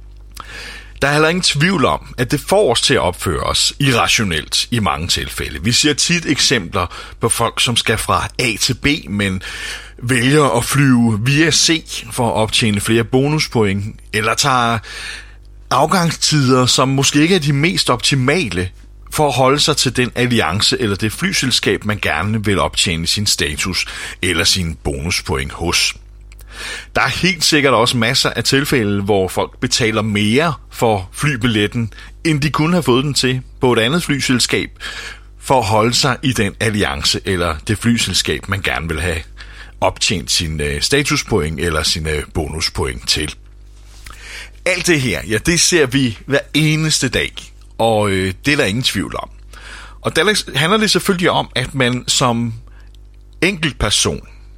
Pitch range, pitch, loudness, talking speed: 100-140 Hz, 115 Hz, -15 LUFS, 160 wpm